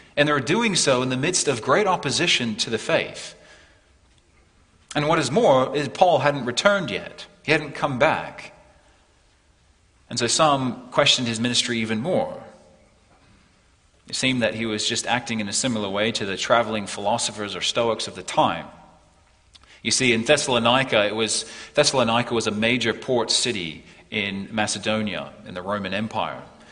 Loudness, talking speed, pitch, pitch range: -22 LUFS, 165 wpm, 115 Hz, 105-135 Hz